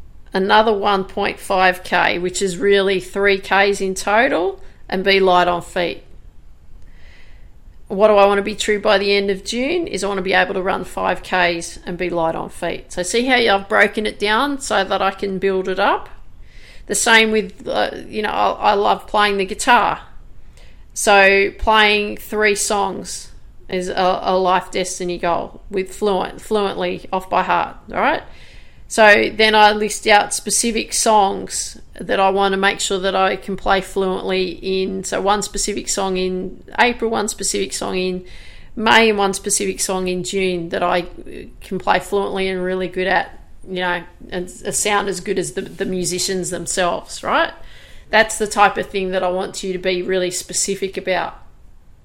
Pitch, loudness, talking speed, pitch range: 195 Hz, -17 LUFS, 180 wpm, 185-205 Hz